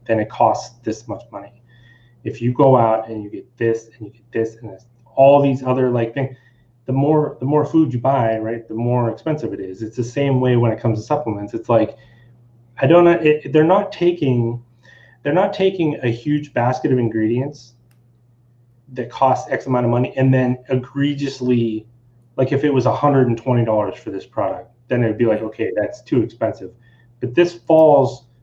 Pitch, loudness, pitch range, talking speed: 120 Hz, -18 LUFS, 115-135 Hz, 195 wpm